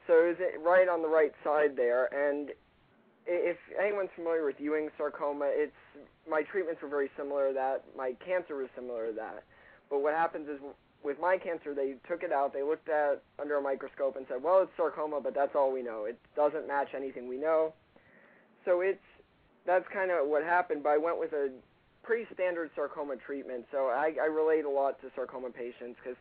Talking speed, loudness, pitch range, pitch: 205 wpm, -32 LUFS, 135-170 Hz, 150 Hz